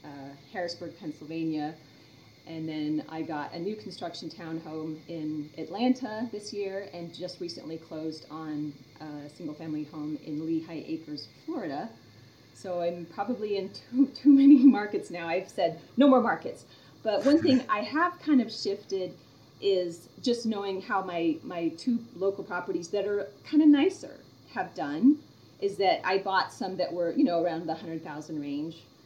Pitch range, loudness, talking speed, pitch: 155-215 Hz, -29 LUFS, 165 wpm, 170 Hz